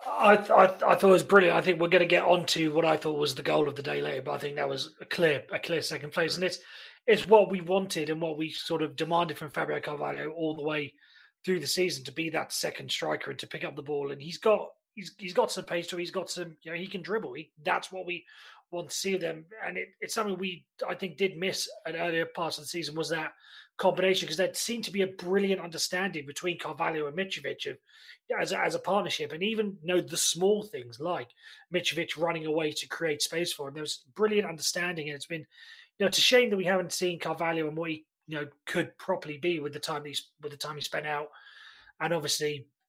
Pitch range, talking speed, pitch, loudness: 155-190 Hz, 255 wpm, 170 Hz, -29 LUFS